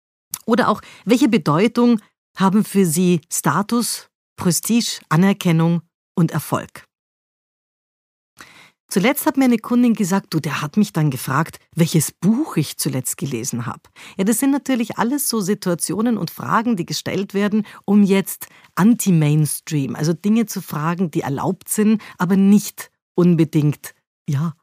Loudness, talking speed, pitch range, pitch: -19 LUFS, 135 wpm, 160-220 Hz, 190 Hz